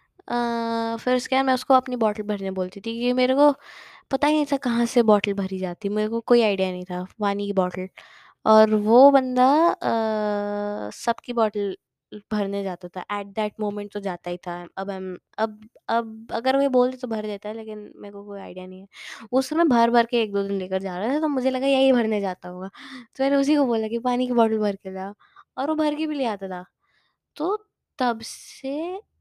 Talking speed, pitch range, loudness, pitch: 220 wpm, 200-255 Hz, -23 LUFS, 220 Hz